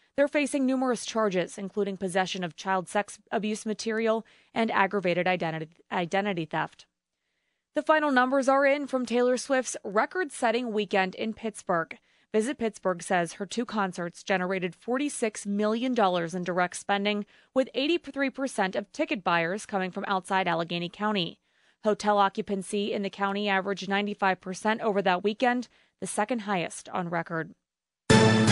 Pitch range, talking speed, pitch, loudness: 185-235 Hz, 135 wpm, 205 Hz, -28 LUFS